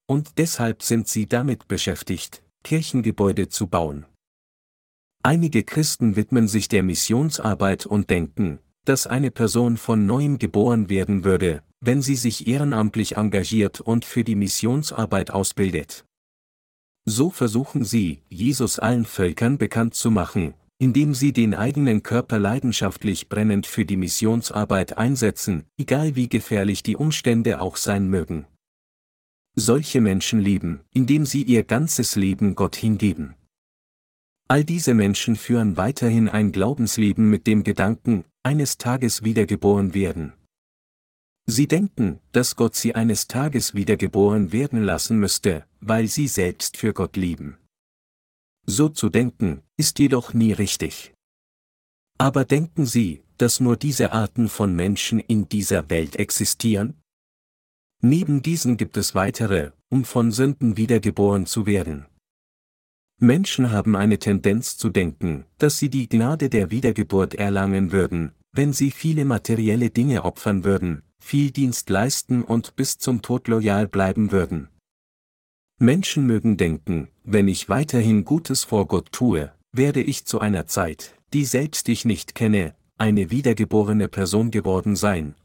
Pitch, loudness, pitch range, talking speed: 110 Hz, -21 LUFS, 95-125 Hz, 135 wpm